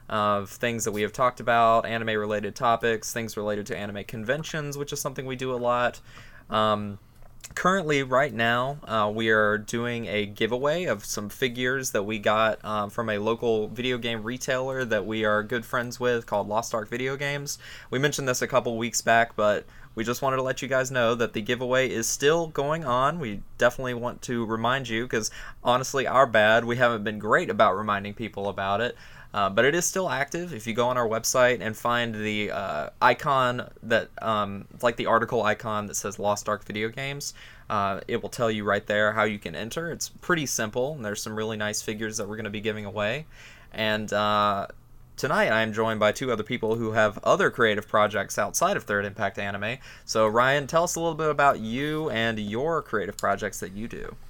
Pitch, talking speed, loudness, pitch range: 115 Hz, 210 wpm, -26 LUFS, 105-125 Hz